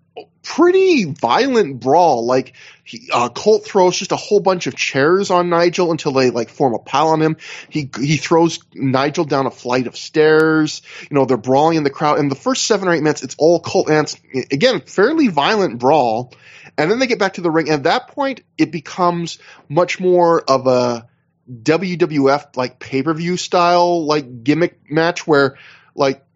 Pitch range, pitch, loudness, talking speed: 135-175 Hz, 155 Hz, -16 LUFS, 190 wpm